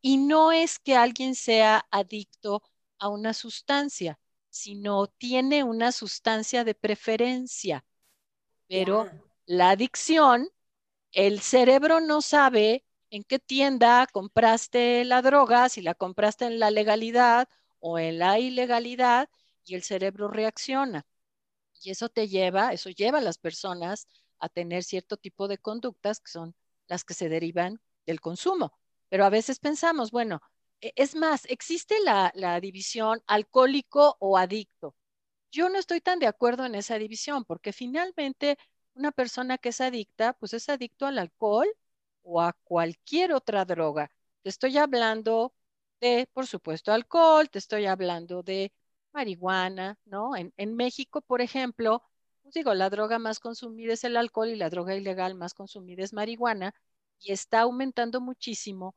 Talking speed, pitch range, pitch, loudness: 150 wpm, 195-255 Hz, 225 Hz, -26 LUFS